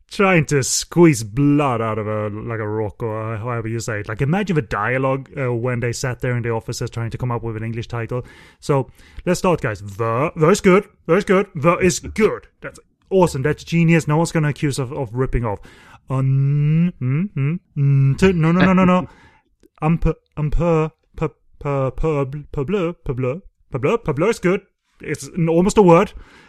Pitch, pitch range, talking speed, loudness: 145 Hz, 120-170 Hz, 190 wpm, -19 LUFS